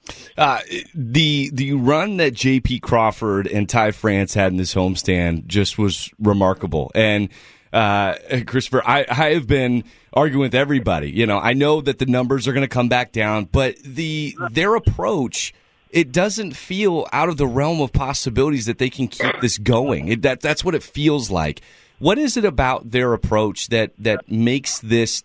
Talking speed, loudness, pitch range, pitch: 180 wpm, -19 LUFS, 105-140 Hz, 125 Hz